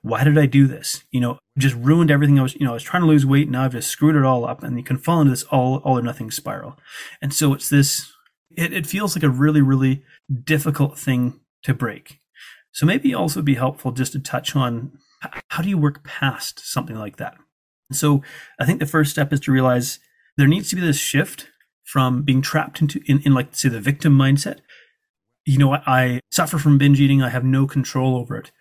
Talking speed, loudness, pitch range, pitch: 230 wpm, -19 LUFS, 130-150 Hz, 140 Hz